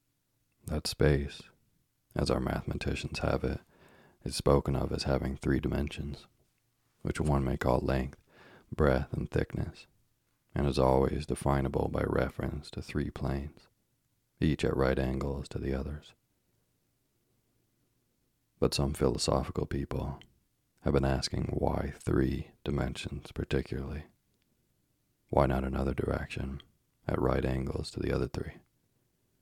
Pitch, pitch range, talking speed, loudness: 70 Hz, 65-75 Hz, 120 wpm, -32 LUFS